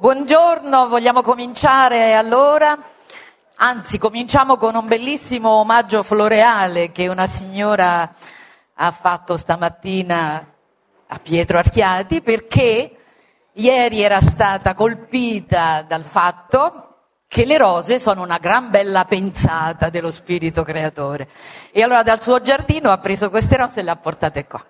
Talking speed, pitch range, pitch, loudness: 125 wpm, 170-245 Hz, 205 Hz, -16 LUFS